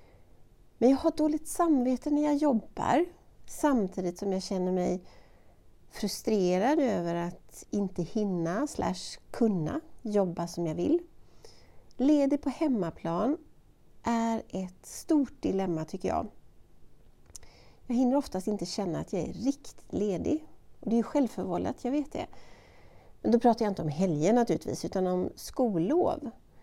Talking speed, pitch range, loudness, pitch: 135 wpm, 185-285 Hz, -30 LUFS, 225 Hz